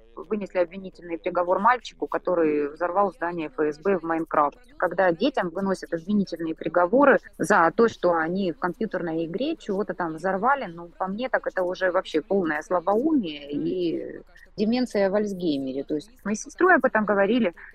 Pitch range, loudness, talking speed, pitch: 165-210 Hz, -24 LUFS, 155 wpm, 185 Hz